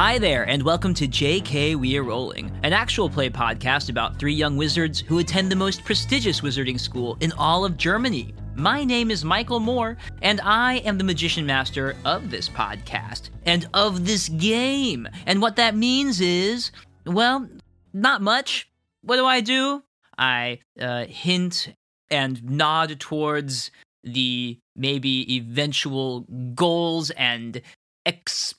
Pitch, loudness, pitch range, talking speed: 160 Hz, -22 LUFS, 130-200 Hz, 145 wpm